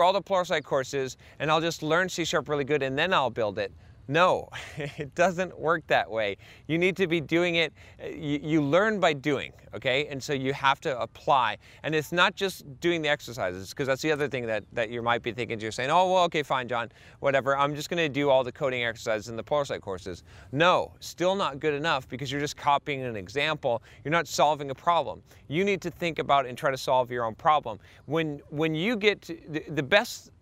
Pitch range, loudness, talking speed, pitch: 125-165 Hz, -27 LUFS, 225 wpm, 145 Hz